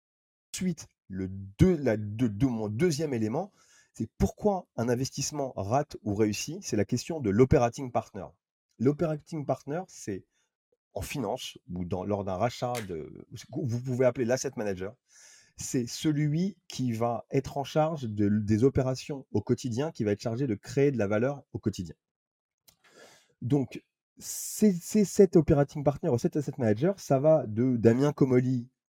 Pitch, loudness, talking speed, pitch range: 130 Hz, -29 LUFS, 160 wpm, 115-150 Hz